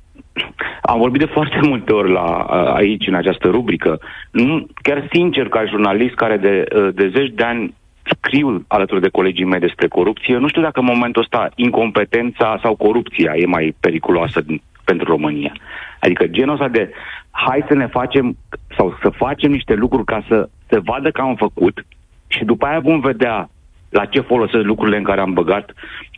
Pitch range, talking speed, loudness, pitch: 105-140 Hz, 175 wpm, -16 LUFS, 120 Hz